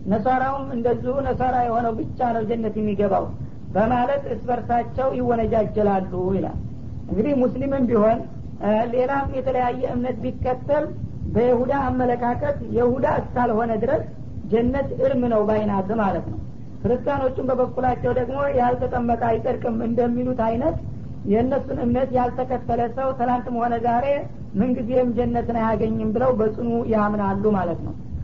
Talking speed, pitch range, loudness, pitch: 110 wpm, 225-255 Hz, -22 LUFS, 240 Hz